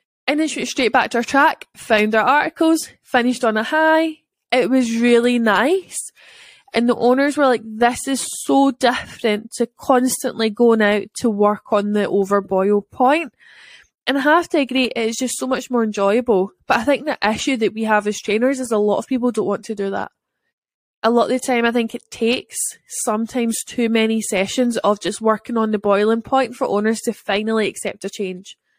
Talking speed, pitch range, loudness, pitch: 200 wpm, 210-255 Hz, -18 LUFS, 235 Hz